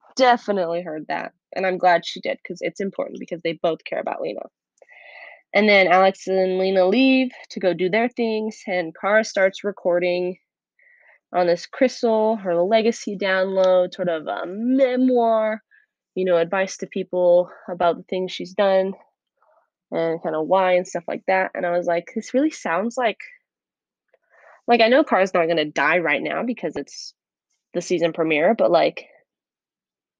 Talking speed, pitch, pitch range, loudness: 170 wpm, 190 Hz, 175-225 Hz, -21 LUFS